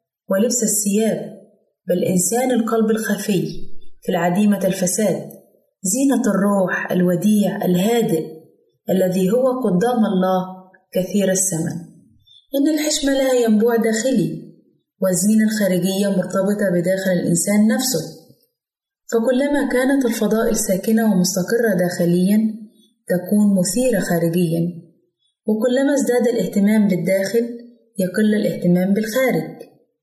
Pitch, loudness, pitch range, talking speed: 205 Hz, -18 LUFS, 185-235 Hz, 90 wpm